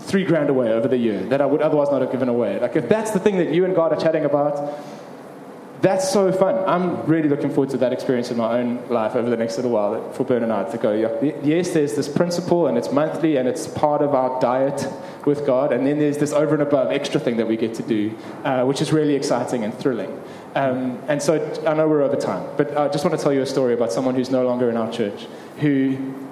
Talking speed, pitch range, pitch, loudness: 260 wpm, 130-155 Hz, 145 Hz, -20 LUFS